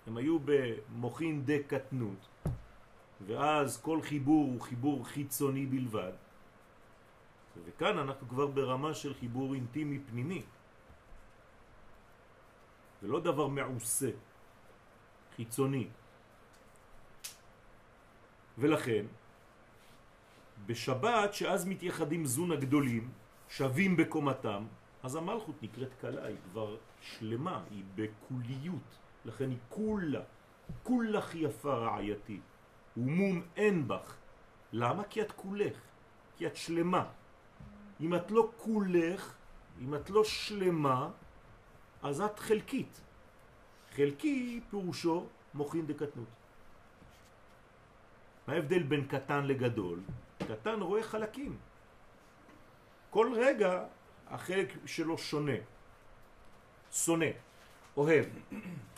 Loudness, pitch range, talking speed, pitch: -35 LUFS, 115-170 Hz, 90 wpm, 145 Hz